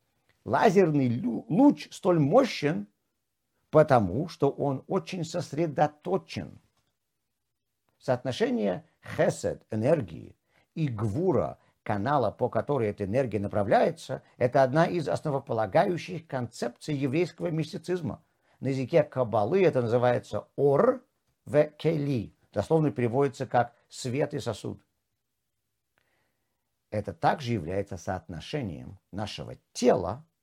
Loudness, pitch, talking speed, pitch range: -28 LUFS, 135 Hz, 95 wpm, 115-160 Hz